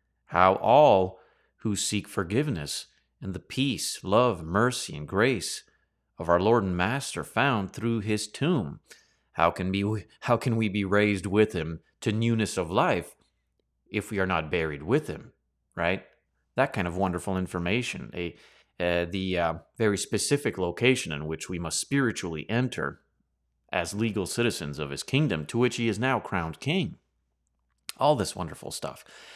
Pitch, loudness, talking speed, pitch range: 100 Hz, -27 LUFS, 160 wpm, 85-115 Hz